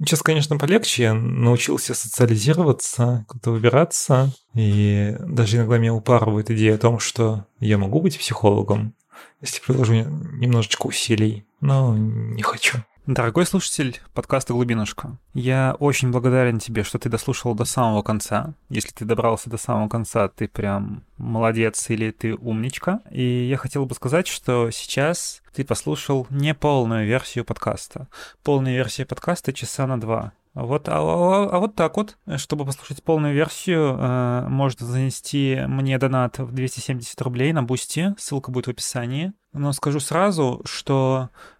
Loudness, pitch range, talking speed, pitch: -21 LUFS, 115-140 Hz, 145 wpm, 125 Hz